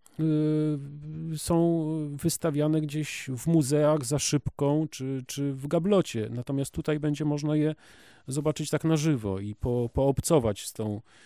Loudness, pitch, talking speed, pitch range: -28 LUFS, 150 Hz, 140 wpm, 135-155 Hz